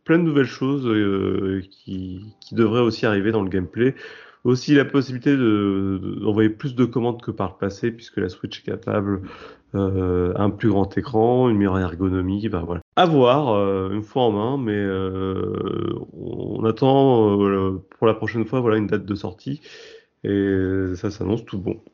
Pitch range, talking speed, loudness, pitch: 95-120 Hz, 180 wpm, -21 LUFS, 105 Hz